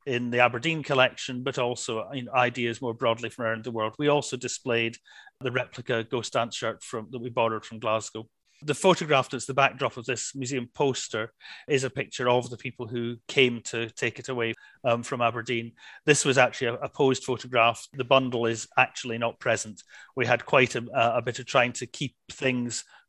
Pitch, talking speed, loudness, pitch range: 125 Hz, 195 wpm, -27 LUFS, 115-130 Hz